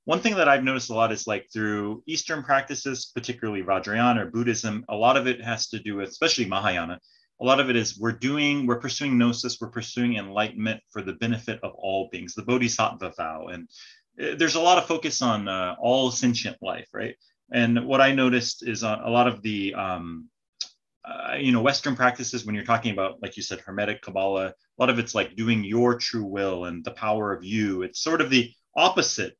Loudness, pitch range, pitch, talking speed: -25 LUFS, 105-130 Hz, 120 Hz, 210 wpm